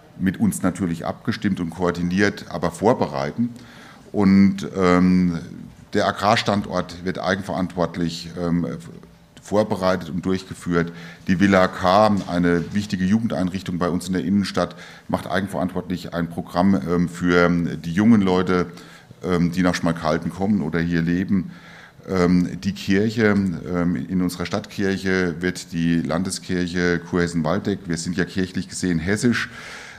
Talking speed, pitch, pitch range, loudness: 125 wpm, 90 Hz, 85-95 Hz, -21 LUFS